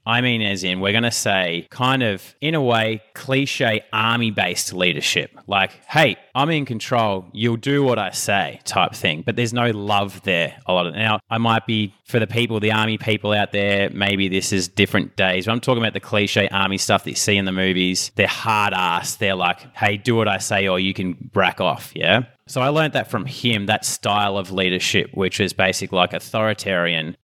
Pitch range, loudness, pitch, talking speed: 95-120 Hz, -19 LUFS, 105 Hz, 215 wpm